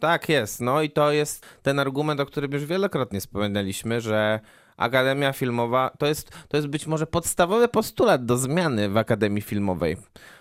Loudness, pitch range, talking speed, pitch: -24 LUFS, 115-155 Hz, 165 wpm, 135 Hz